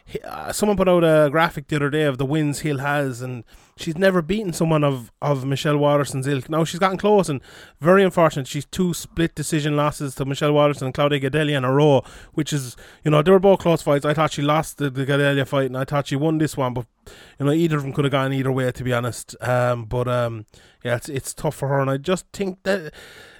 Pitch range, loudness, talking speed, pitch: 135-160 Hz, -21 LUFS, 245 wpm, 145 Hz